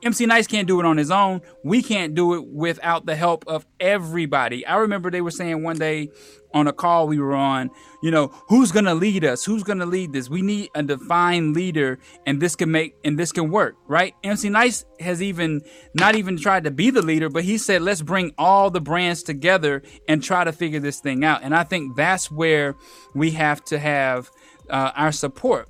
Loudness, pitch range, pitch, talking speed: -21 LUFS, 150-185 Hz, 165 Hz, 220 wpm